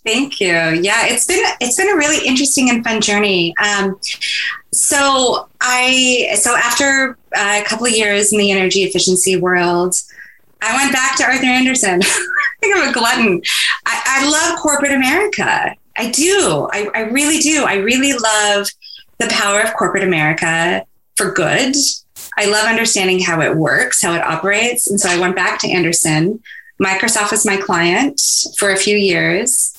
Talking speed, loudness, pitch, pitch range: 165 wpm, -13 LUFS, 215 Hz, 190-265 Hz